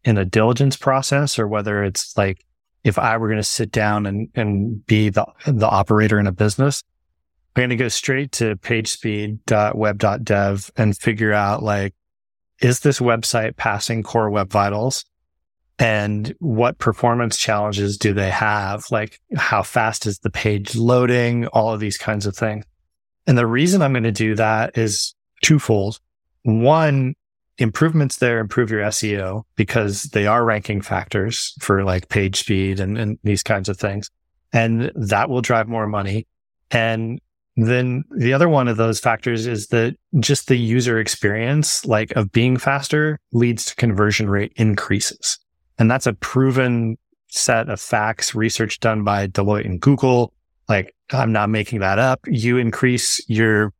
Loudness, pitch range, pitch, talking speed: -19 LUFS, 105-120 Hz, 110 Hz, 160 wpm